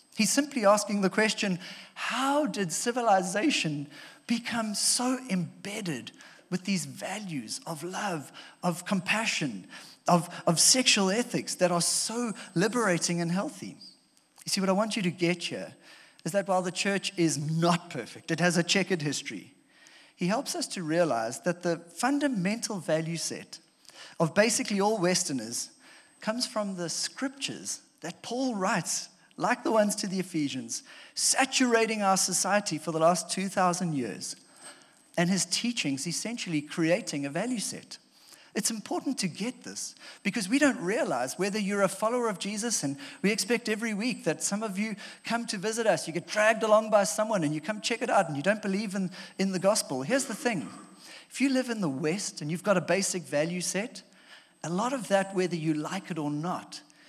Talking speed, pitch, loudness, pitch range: 175 wpm, 195 Hz, -28 LUFS, 170-225 Hz